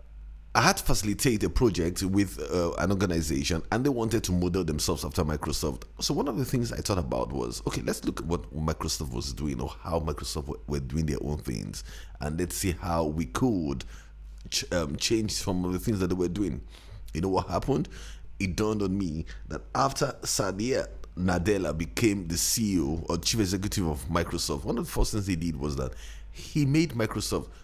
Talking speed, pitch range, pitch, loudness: 200 wpm, 75-100 Hz, 85 Hz, -29 LUFS